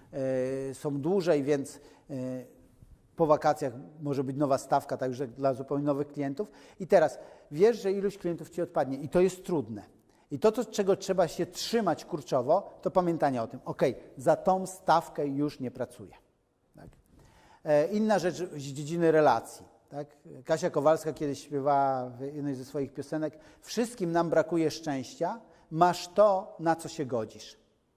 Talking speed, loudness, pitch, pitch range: 150 wpm, -29 LUFS, 150 Hz, 140-175 Hz